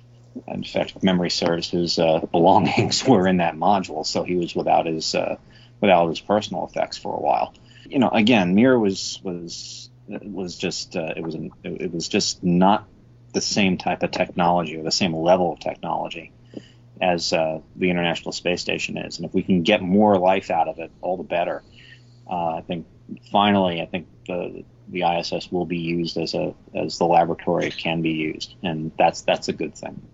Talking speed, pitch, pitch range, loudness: 195 wpm, 90 Hz, 85-105 Hz, -22 LUFS